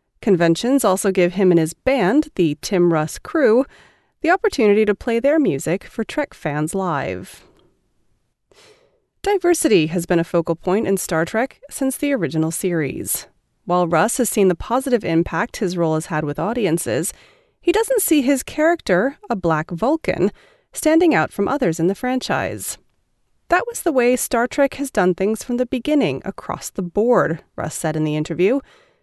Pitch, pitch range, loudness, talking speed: 215 Hz, 170-280 Hz, -19 LUFS, 170 wpm